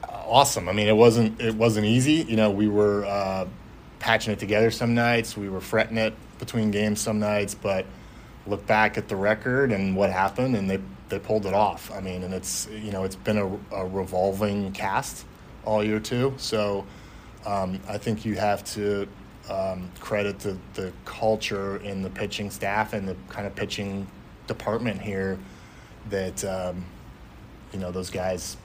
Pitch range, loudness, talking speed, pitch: 95-110 Hz, -25 LUFS, 180 wpm, 105 Hz